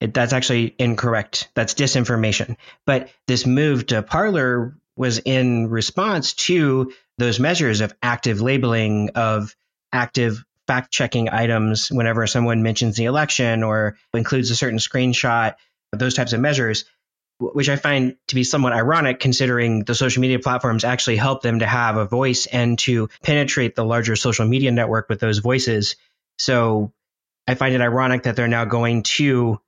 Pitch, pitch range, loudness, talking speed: 120 Hz, 115-130 Hz, -19 LUFS, 155 wpm